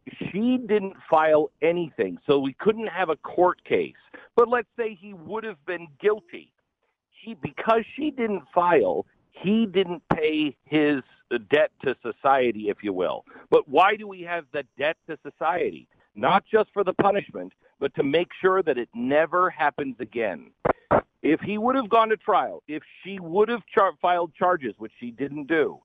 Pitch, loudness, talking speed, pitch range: 185 Hz, -24 LUFS, 175 wpm, 150-220 Hz